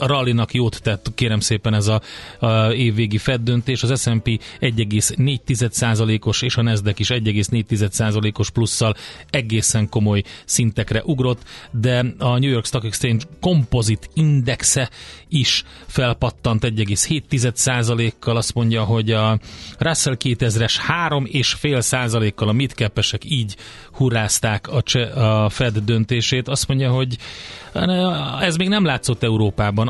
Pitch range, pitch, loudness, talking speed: 110-130 Hz, 115 Hz, -19 LUFS, 110 wpm